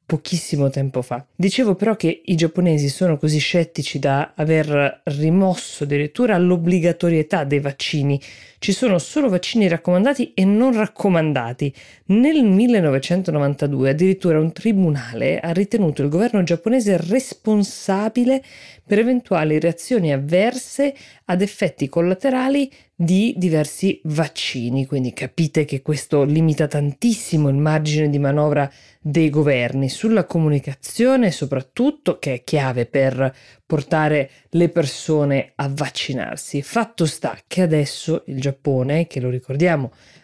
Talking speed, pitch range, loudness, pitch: 120 wpm, 140-190 Hz, -19 LUFS, 160 Hz